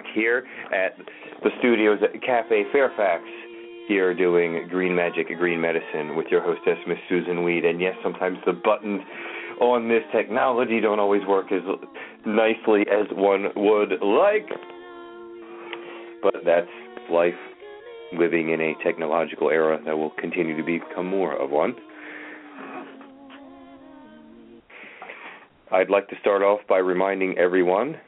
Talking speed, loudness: 130 wpm, -23 LUFS